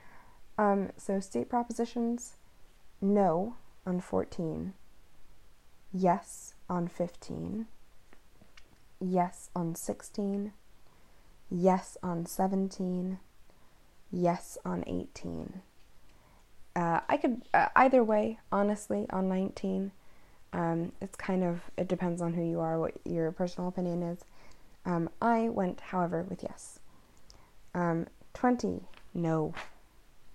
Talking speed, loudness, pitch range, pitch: 105 wpm, -32 LUFS, 170-200 Hz, 180 Hz